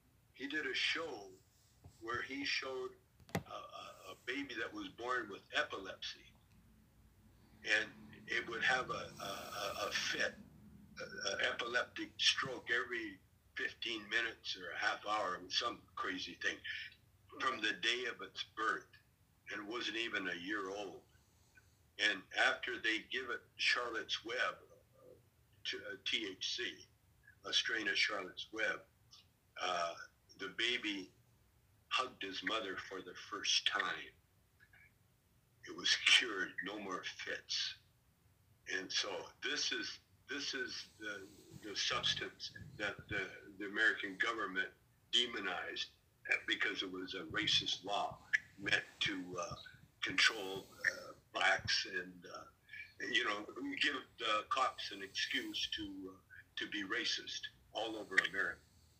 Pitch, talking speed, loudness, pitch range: 385 Hz, 130 wpm, -38 LUFS, 325-465 Hz